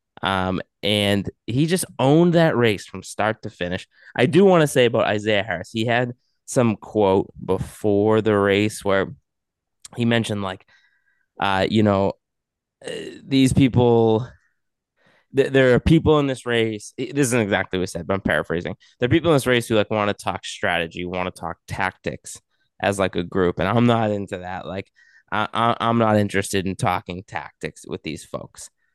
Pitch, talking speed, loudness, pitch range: 105 Hz, 185 wpm, -21 LUFS, 95-120 Hz